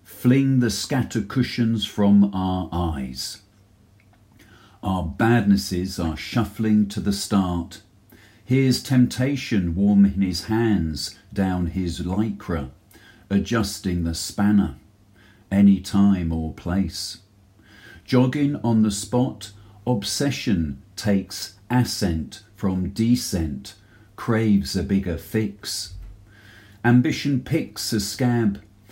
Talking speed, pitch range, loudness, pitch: 95 wpm, 95-110 Hz, -22 LUFS, 100 Hz